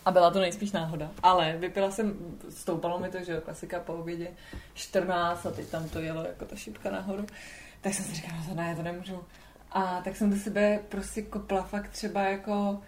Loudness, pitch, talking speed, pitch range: -31 LUFS, 185 Hz, 210 wpm, 170-200 Hz